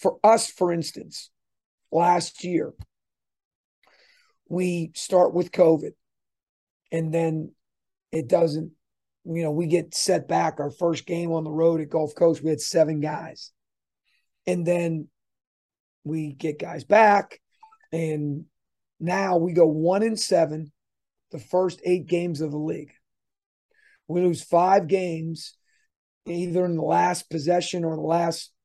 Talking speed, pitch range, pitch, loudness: 135 wpm, 160-180 Hz, 170 Hz, -24 LUFS